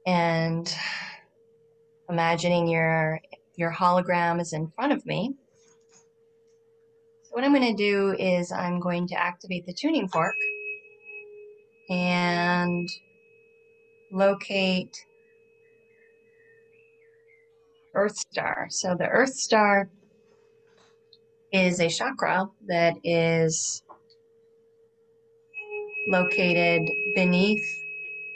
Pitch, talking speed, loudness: 255 Hz, 85 wpm, -25 LUFS